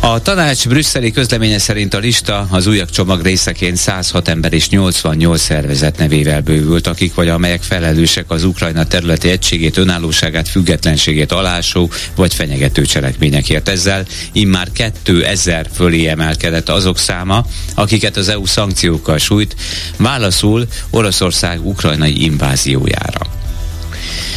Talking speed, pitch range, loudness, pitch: 120 wpm, 80-100 Hz, -12 LUFS, 90 Hz